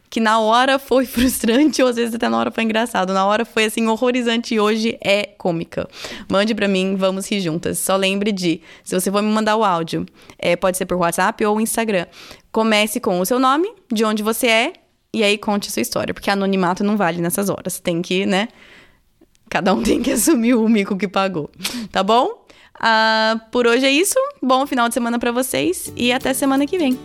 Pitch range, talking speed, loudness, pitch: 195-245 Hz, 215 wpm, -18 LUFS, 220 Hz